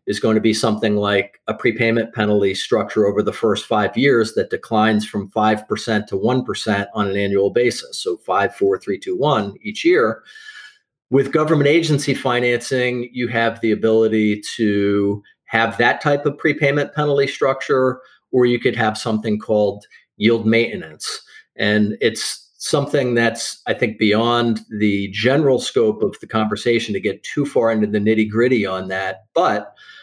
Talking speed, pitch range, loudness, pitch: 160 wpm, 105-130 Hz, -18 LUFS, 115 Hz